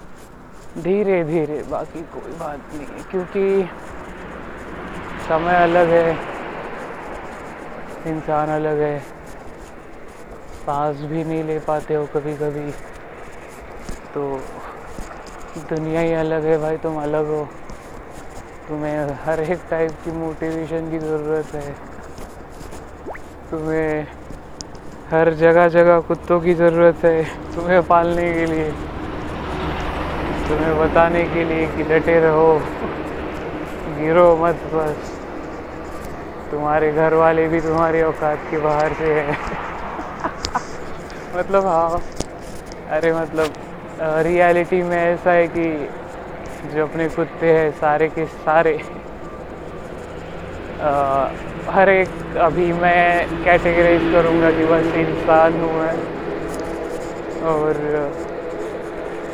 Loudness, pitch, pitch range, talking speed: -19 LUFS, 160 Hz, 150-170 Hz, 100 wpm